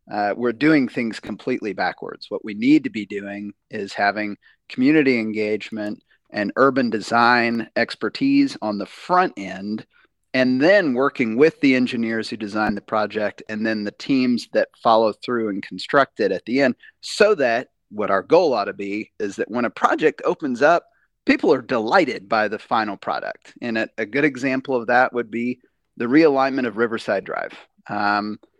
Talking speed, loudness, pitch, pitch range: 175 wpm, -21 LUFS, 115 Hz, 105-130 Hz